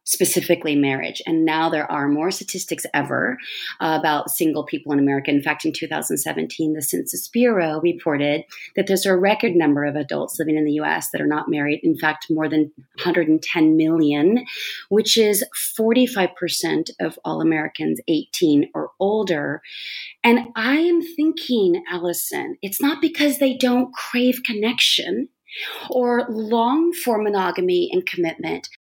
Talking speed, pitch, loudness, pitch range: 150 wpm, 180 Hz, -20 LUFS, 155-245 Hz